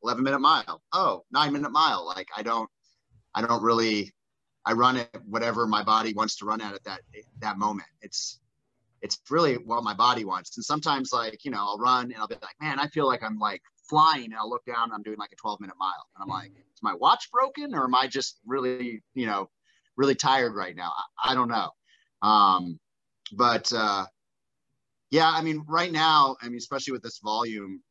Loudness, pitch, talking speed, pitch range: -26 LUFS, 120 Hz, 210 wpm, 110-135 Hz